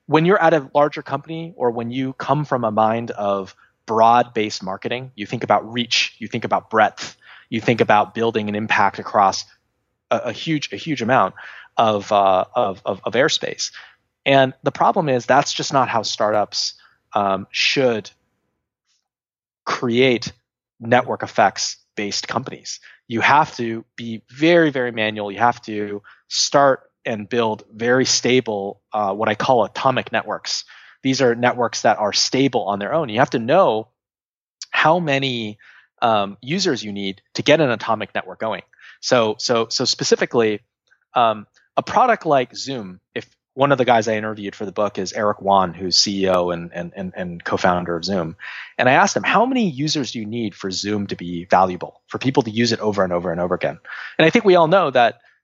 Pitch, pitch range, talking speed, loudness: 115 Hz, 105-135 Hz, 185 wpm, -19 LUFS